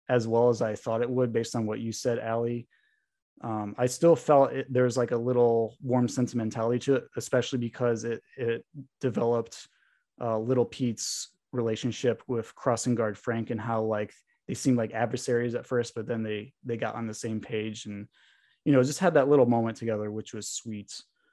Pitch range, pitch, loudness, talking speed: 115-125 Hz, 120 Hz, -28 LUFS, 195 wpm